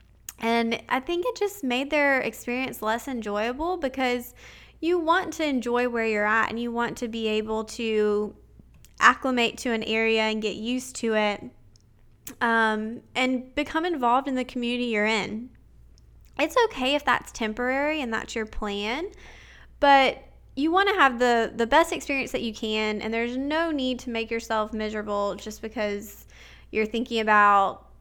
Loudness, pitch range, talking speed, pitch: -25 LUFS, 220-265 Hz, 165 wpm, 235 Hz